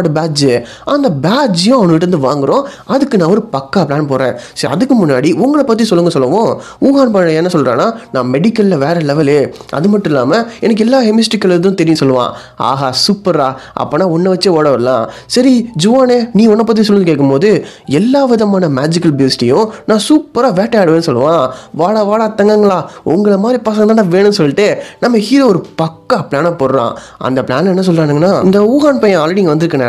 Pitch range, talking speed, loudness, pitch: 150-220 Hz, 160 wpm, -11 LUFS, 190 Hz